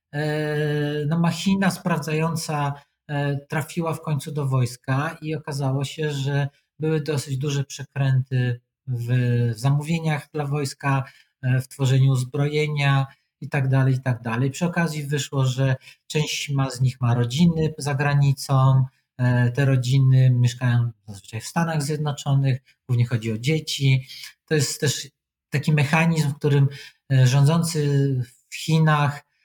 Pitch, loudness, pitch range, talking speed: 140 Hz, -23 LUFS, 130-150 Hz, 120 wpm